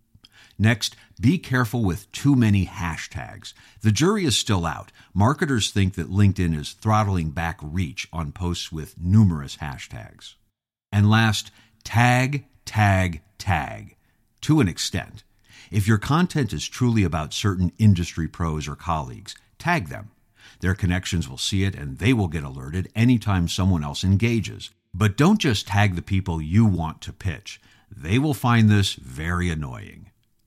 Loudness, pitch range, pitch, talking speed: -23 LUFS, 90-115 Hz, 100 Hz, 150 wpm